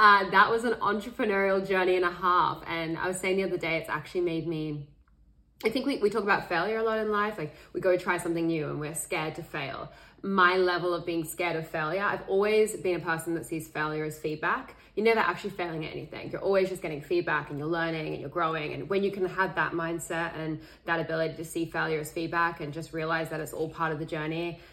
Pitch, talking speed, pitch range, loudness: 170 Hz, 245 wpm, 160-190 Hz, -29 LUFS